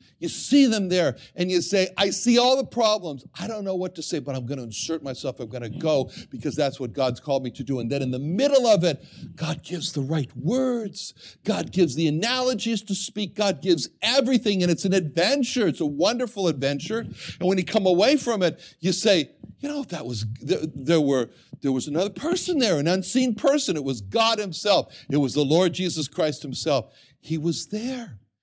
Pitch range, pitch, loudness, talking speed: 140-220 Hz, 175 Hz, -24 LUFS, 215 wpm